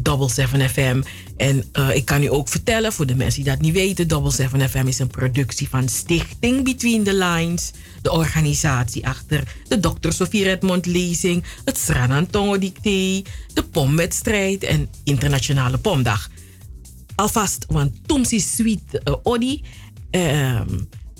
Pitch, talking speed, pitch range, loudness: 145 Hz, 140 wpm, 130-185 Hz, -20 LUFS